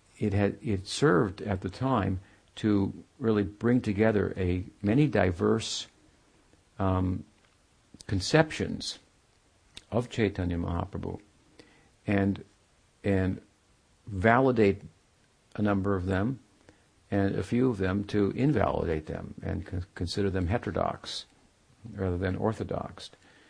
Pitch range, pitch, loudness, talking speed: 95-110 Hz, 100 Hz, -29 LUFS, 105 wpm